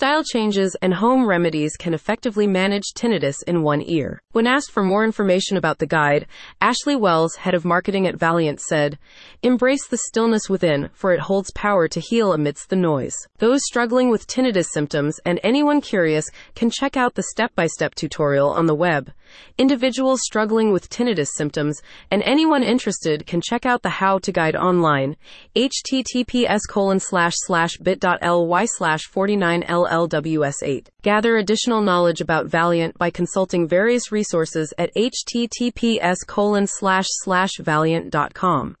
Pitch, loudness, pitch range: 190 Hz, -19 LUFS, 165-225 Hz